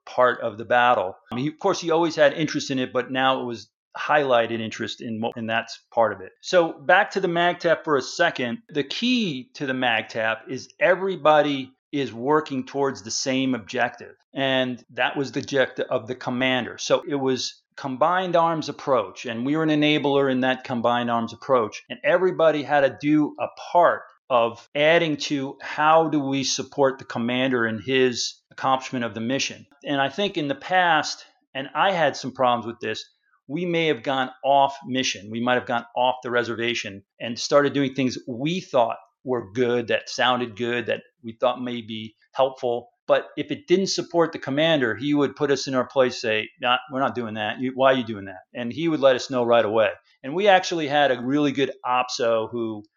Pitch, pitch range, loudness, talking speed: 130 Hz, 120-150 Hz, -23 LUFS, 200 wpm